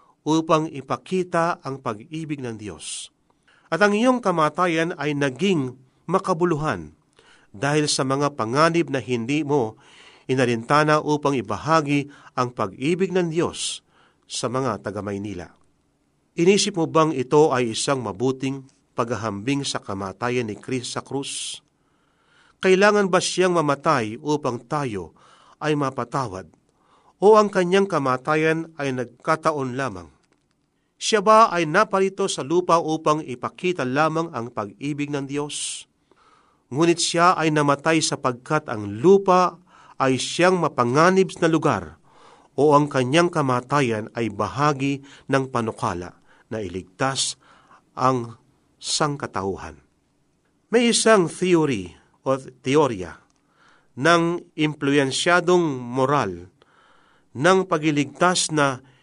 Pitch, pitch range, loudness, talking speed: 145 Hz, 125-165 Hz, -22 LUFS, 110 wpm